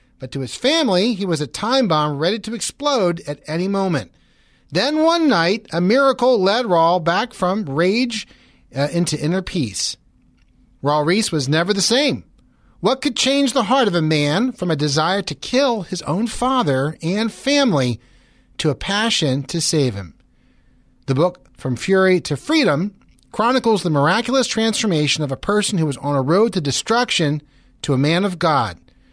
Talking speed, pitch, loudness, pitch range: 175 wpm, 180 Hz, -18 LUFS, 150-225 Hz